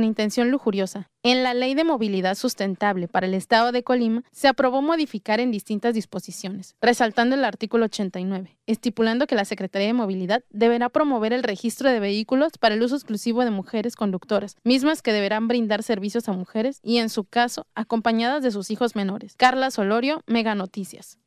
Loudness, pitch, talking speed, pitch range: -23 LUFS, 225 Hz, 180 wpm, 205-245 Hz